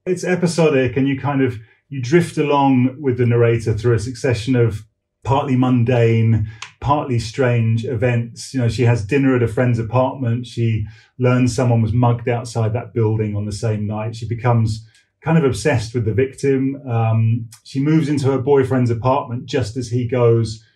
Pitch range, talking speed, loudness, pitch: 115-135 Hz, 175 wpm, -18 LUFS, 120 Hz